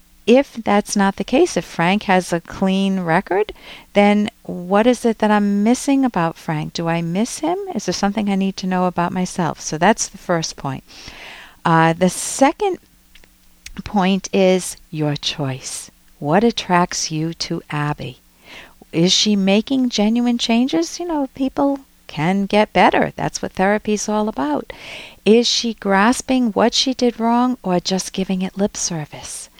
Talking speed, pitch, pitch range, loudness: 160 wpm, 200 Hz, 180-235 Hz, -18 LUFS